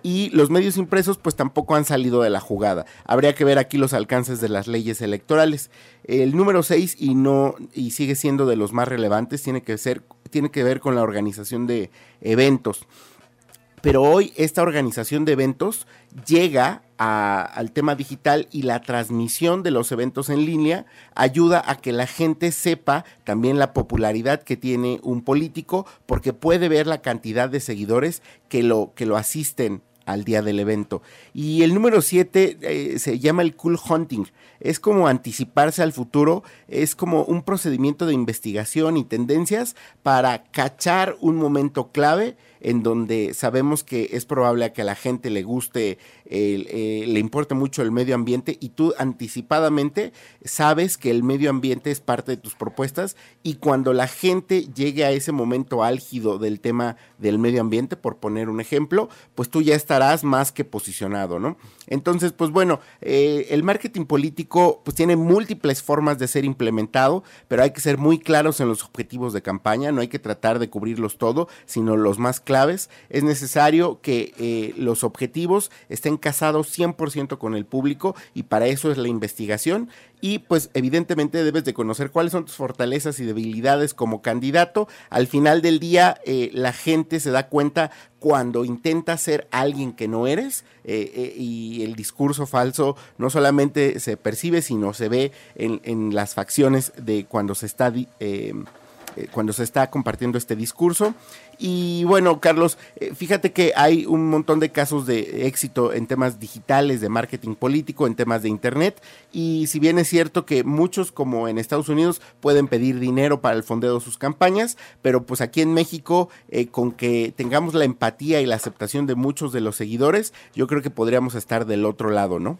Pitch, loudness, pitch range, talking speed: 135 Hz, -21 LUFS, 120-155 Hz, 175 wpm